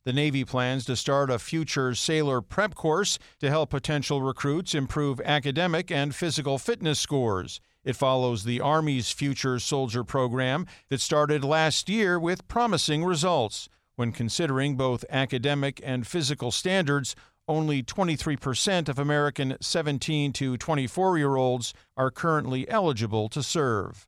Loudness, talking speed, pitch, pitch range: -26 LUFS, 135 wpm, 140 Hz, 130-155 Hz